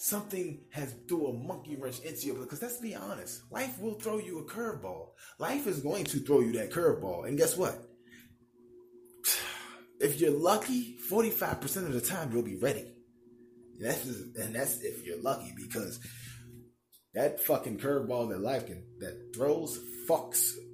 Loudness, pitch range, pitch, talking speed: -33 LUFS, 120-160 Hz, 120 Hz, 160 wpm